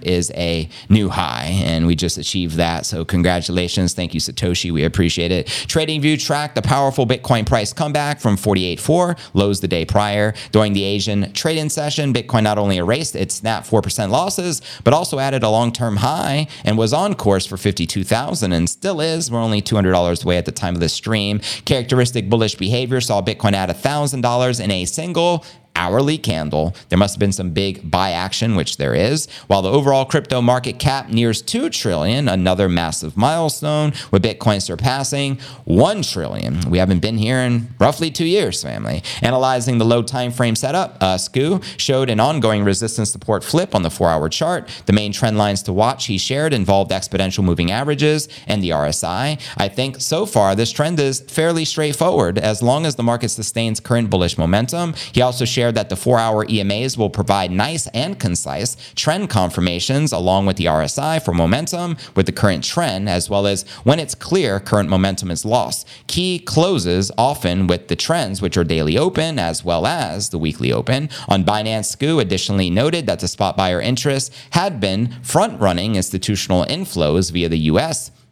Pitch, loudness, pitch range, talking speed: 110 Hz, -18 LUFS, 95-135 Hz, 185 wpm